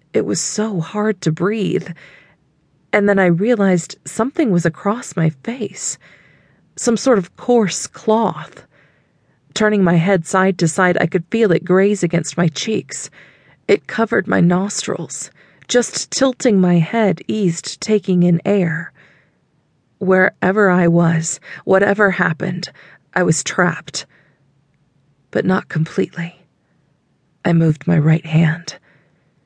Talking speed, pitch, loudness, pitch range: 125 wpm, 180 Hz, -17 LUFS, 165-205 Hz